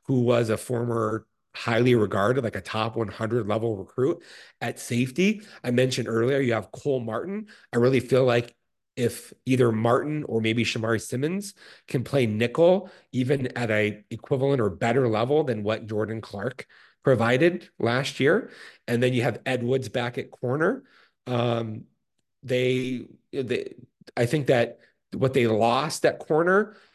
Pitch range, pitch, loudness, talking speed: 115-135 Hz, 120 Hz, -25 LUFS, 155 wpm